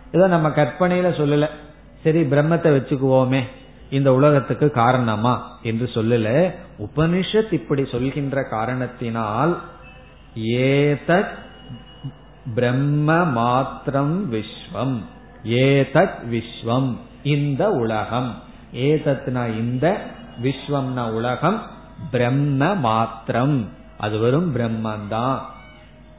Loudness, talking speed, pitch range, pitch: -20 LUFS, 75 wpm, 120-150 Hz, 135 Hz